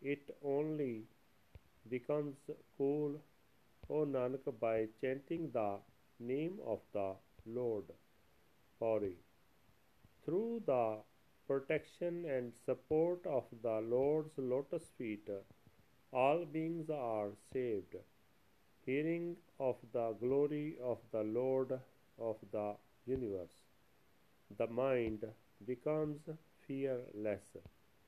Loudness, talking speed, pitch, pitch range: -40 LUFS, 90 wpm, 130 Hz, 110-150 Hz